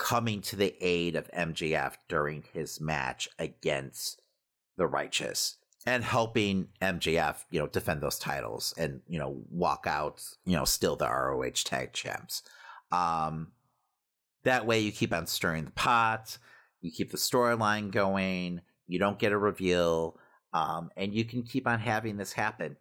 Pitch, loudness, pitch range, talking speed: 100 Hz, -31 LUFS, 85-115 Hz, 160 wpm